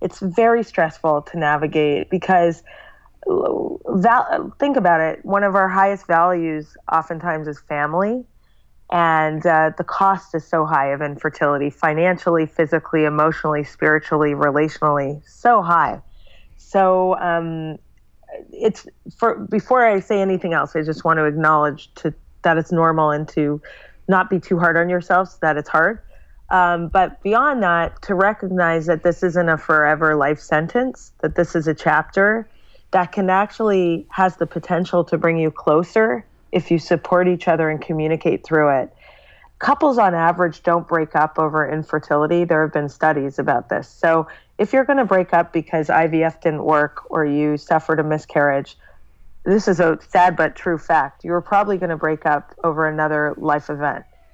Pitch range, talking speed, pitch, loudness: 155-185 Hz, 160 wpm, 165 Hz, -18 LUFS